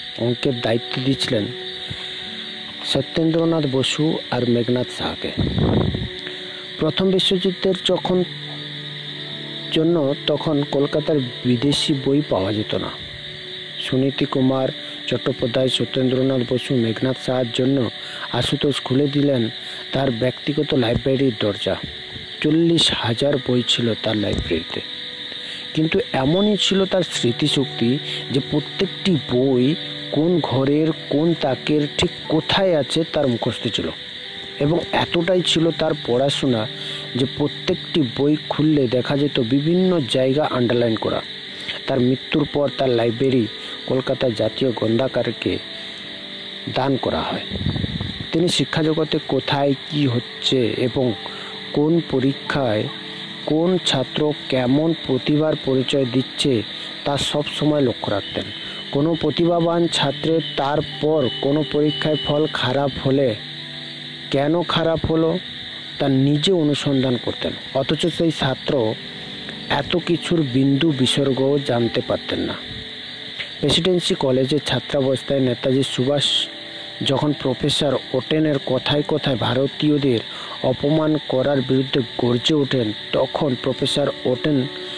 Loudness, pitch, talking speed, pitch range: -20 LUFS, 140 Hz, 105 wpm, 130-155 Hz